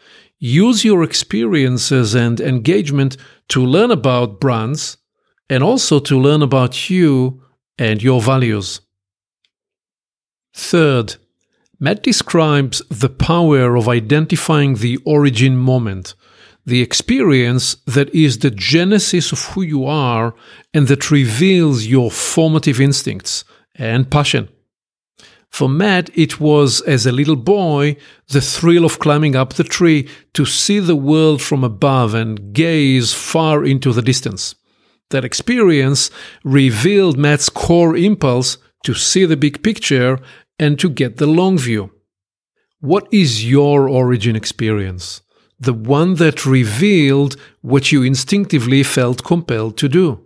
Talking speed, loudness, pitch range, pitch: 125 wpm, -14 LUFS, 125-155 Hz, 140 Hz